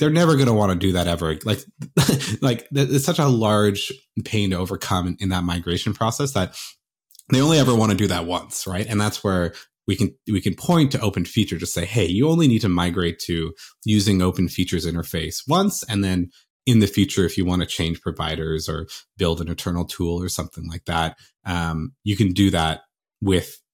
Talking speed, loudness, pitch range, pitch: 210 wpm, -21 LUFS, 85-110 Hz, 95 Hz